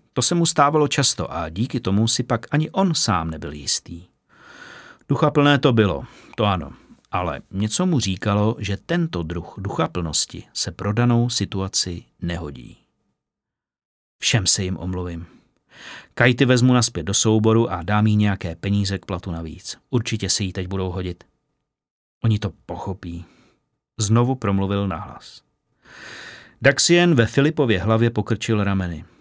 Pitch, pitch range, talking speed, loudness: 105 Hz, 90-120 Hz, 140 wpm, -20 LUFS